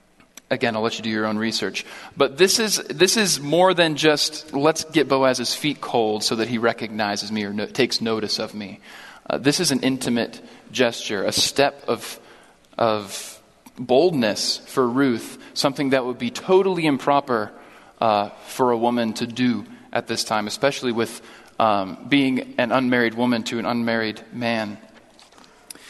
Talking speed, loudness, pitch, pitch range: 165 wpm, -21 LUFS, 120 Hz, 110-145 Hz